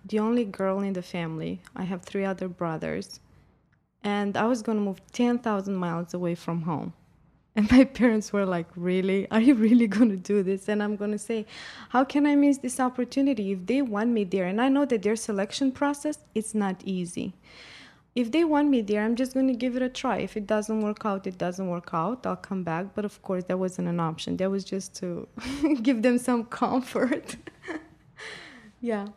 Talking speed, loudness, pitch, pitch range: 210 wpm, -27 LUFS, 210 Hz, 190-245 Hz